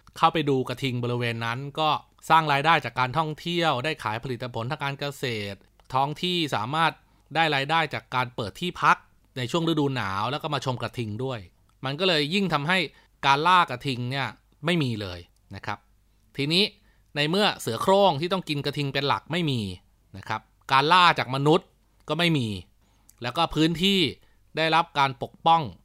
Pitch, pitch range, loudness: 140 Hz, 115-160 Hz, -25 LUFS